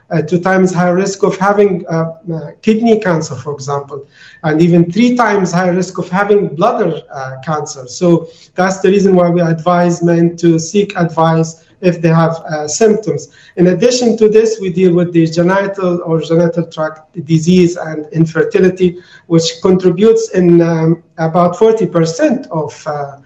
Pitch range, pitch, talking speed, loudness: 165-190 Hz, 175 Hz, 165 wpm, -12 LUFS